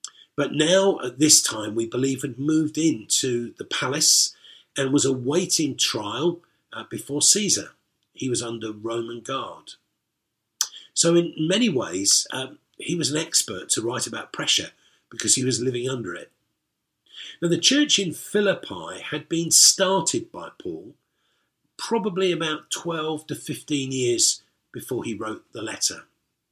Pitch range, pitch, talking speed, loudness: 130-190 Hz, 155 Hz, 140 wpm, -22 LUFS